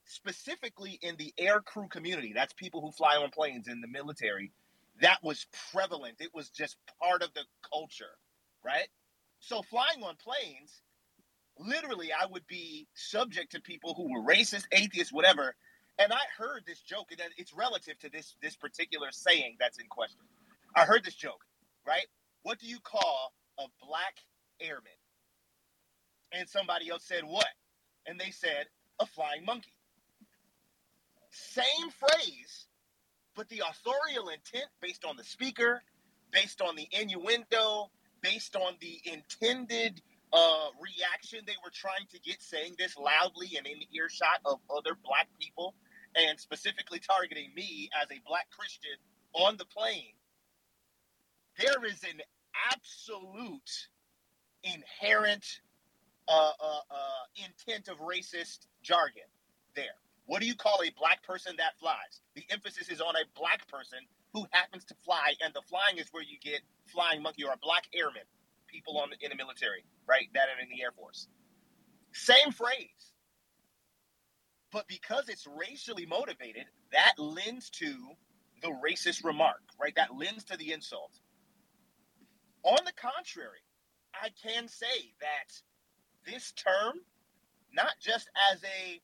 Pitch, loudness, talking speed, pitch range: 190 Hz, -32 LUFS, 150 wpm, 160-230 Hz